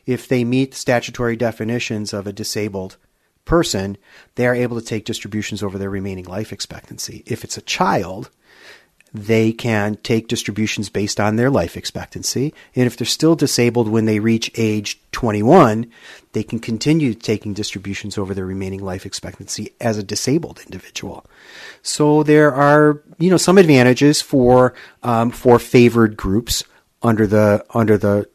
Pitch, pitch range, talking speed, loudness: 115 Hz, 105-125 Hz, 155 wpm, -17 LUFS